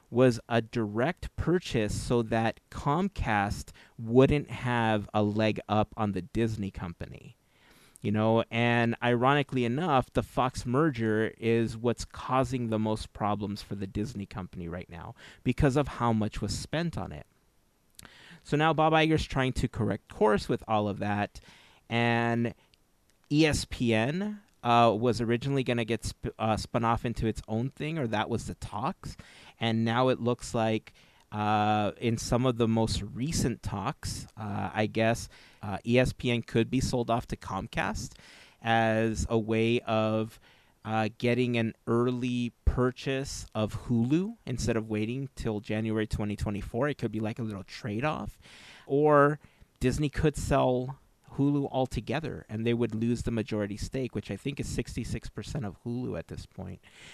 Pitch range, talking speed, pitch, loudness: 110-125 Hz, 155 wpm, 115 Hz, -29 LUFS